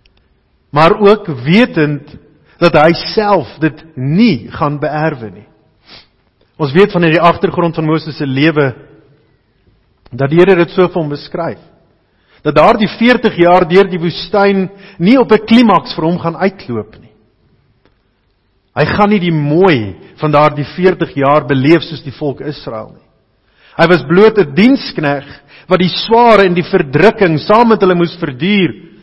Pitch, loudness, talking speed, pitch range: 160 Hz, -11 LUFS, 155 wpm, 140-185 Hz